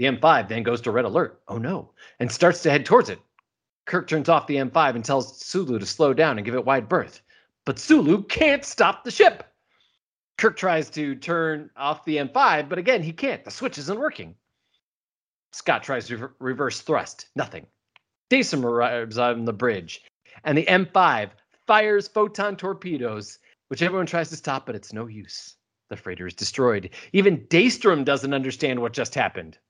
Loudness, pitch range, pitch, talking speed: -22 LUFS, 125-180 Hz, 150 Hz, 180 wpm